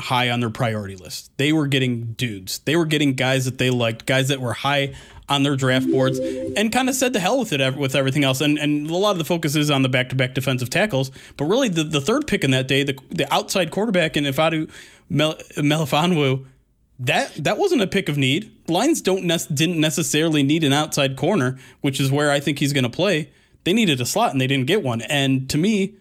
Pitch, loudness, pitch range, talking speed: 140 Hz, -20 LUFS, 130-160 Hz, 235 wpm